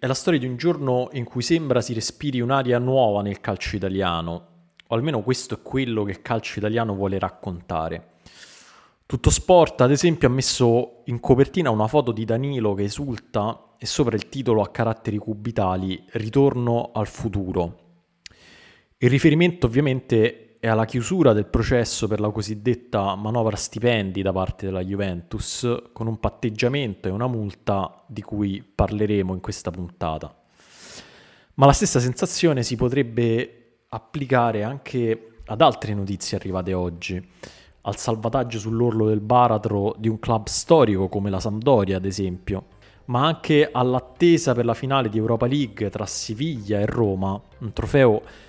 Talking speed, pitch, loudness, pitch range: 150 wpm, 115 Hz, -22 LUFS, 100-125 Hz